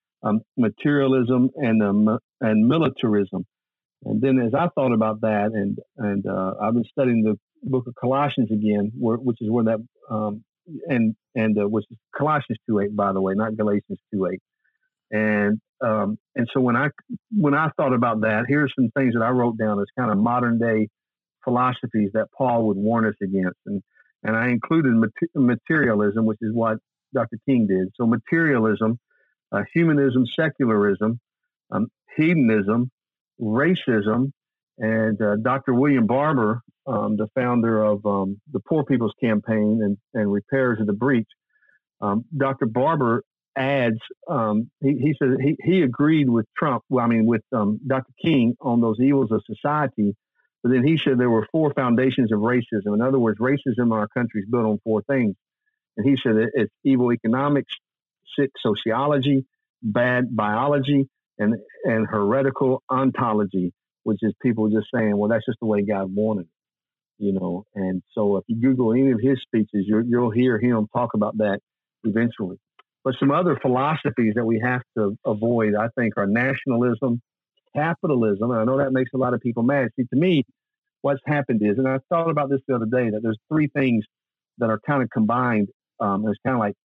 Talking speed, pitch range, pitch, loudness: 180 wpm, 110-135 Hz, 120 Hz, -22 LUFS